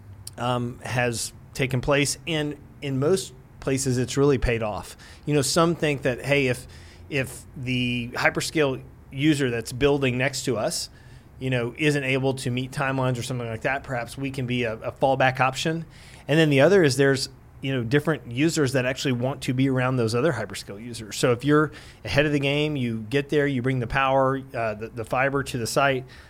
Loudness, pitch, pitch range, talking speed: -24 LUFS, 130 Hz, 120-140 Hz, 200 wpm